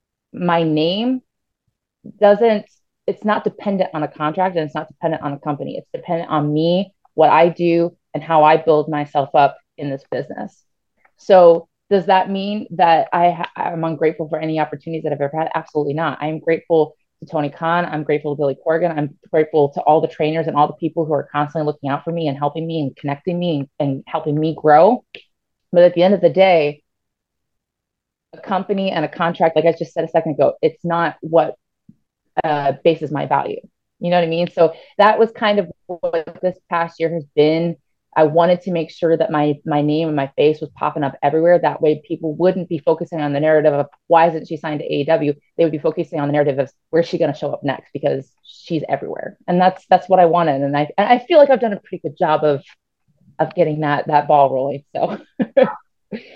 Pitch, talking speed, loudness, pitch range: 160 Hz, 220 wpm, -17 LUFS, 150-175 Hz